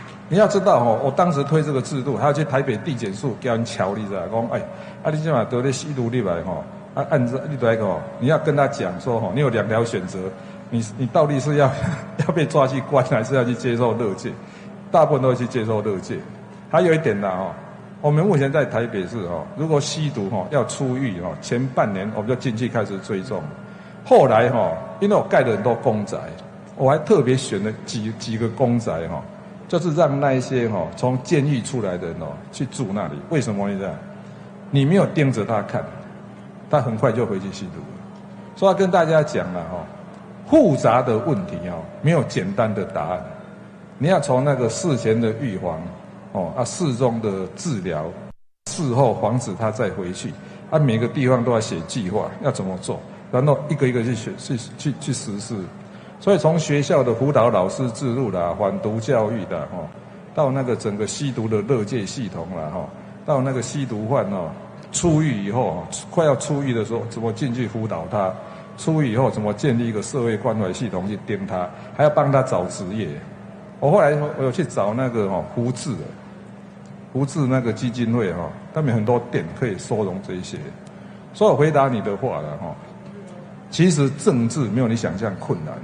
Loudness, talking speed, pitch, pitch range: -21 LUFS, 280 characters per minute, 130 Hz, 115-155 Hz